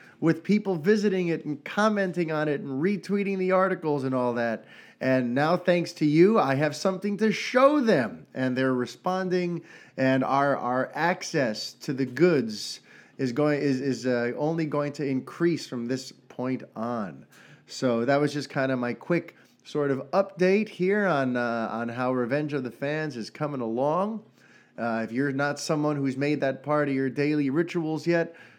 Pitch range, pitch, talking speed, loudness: 130-180 Hz, 145 Hz, 180 wpm, -26 LUFS